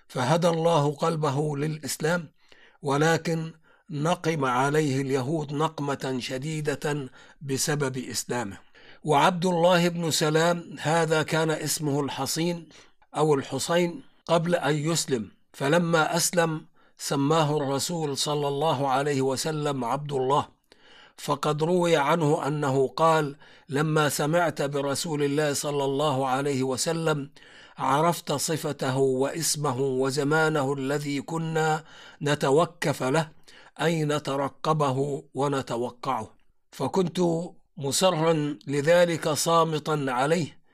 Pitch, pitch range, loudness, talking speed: 150 Hz, 140-165 Hz, -25 LUFS, 95 wpm